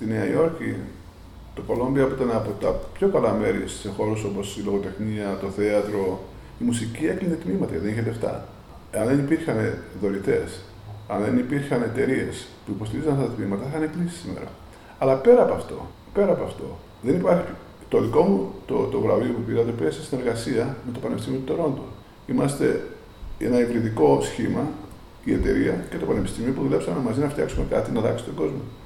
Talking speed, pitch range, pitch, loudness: 185 wpm, 100-130 Hz, 110 Hz, -24 LUFS